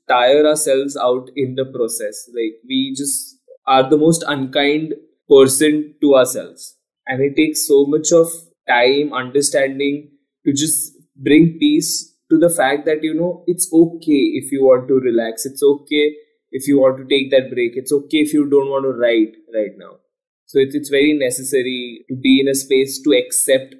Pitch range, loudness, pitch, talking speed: 135-165 Hz, -16 LUFS, 145 Hz, 180 wpm